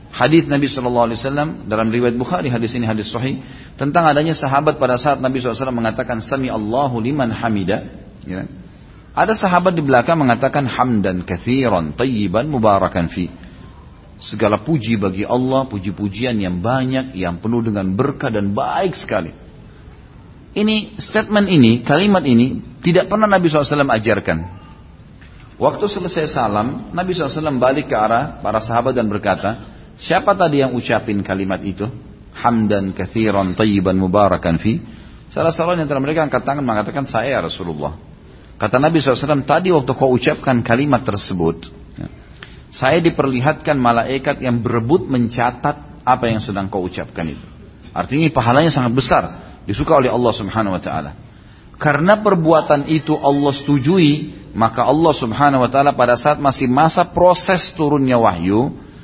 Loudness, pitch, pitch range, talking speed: -17 LUFS, 125 Hz, 105-150 Hz, 140 wpm